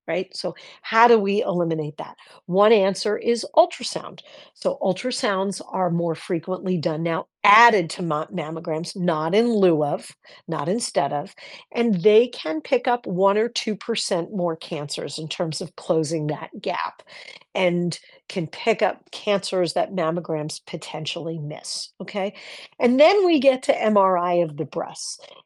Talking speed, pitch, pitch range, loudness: 155 wpm, 185 Hz, 165-220 Hz, -22 LUFS